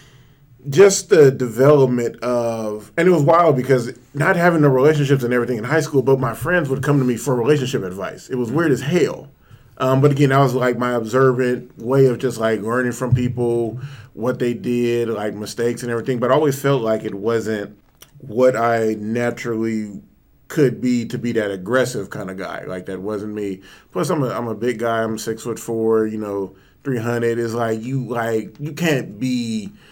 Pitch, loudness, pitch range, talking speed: 125 Hz, -19 LUFS, 115-135 Hz, 200 wpm